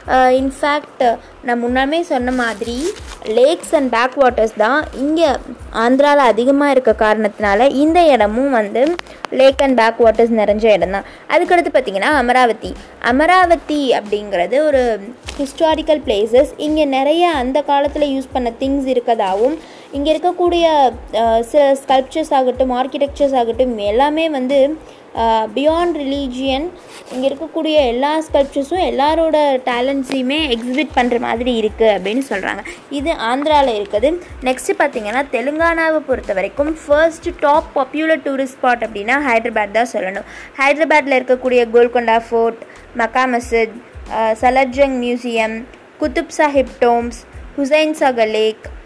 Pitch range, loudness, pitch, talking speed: 235-300 Hz, -15 LUFS, 270 Hz, 115 wpm